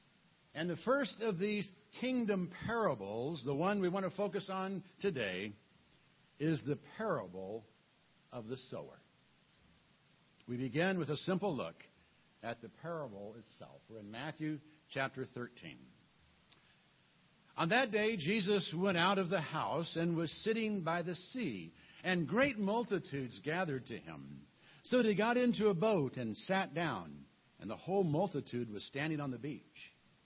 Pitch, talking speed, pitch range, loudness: 165 Hz, 150 wpm, 135-200 Hz, -37 LUFS